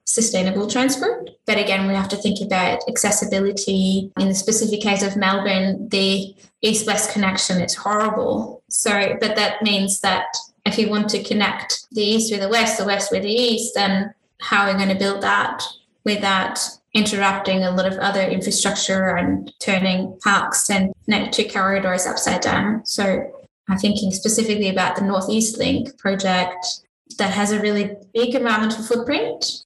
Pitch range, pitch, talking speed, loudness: 195-220 Hz, 200 Hz, 165 wpm, -19 LUFS